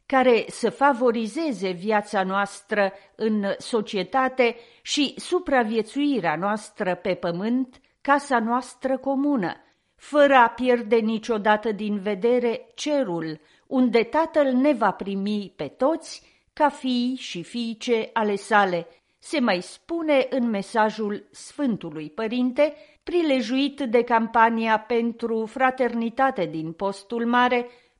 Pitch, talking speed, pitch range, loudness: 235 Hz, 105 wpm, 210-265 Hz, -23 LUFS